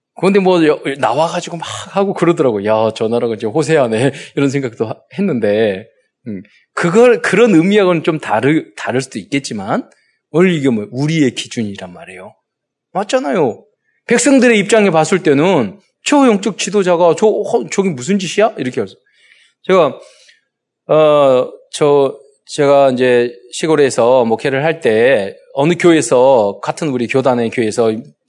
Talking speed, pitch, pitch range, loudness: 305 characters per minute, 160 Hz, 135-205 Hz, -13 LUFS